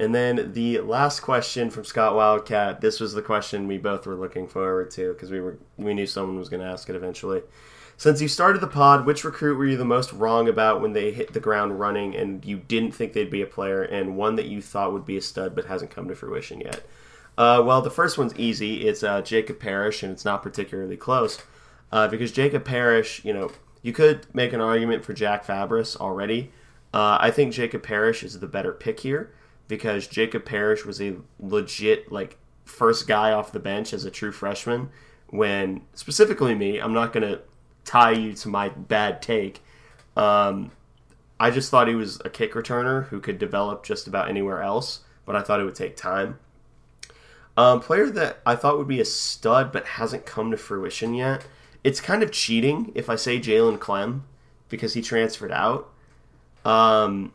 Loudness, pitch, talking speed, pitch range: -23 LUFS, 115 Hz, 200 wpm, 100-130 Hz